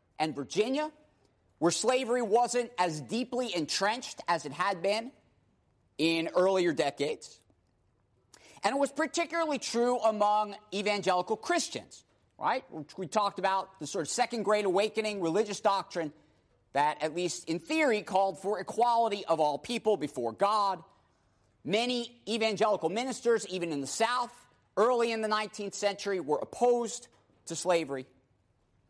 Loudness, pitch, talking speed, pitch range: -30 LUFS, 200 Hz, 135 wpm, 160-230 Hz